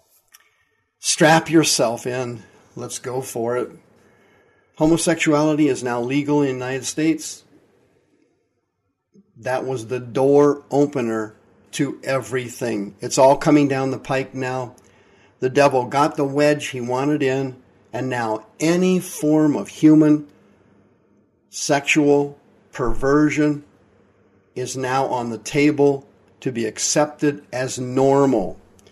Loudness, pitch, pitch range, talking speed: -19 LUFS, 135 Hz, 120-150 Hz, 115 wpm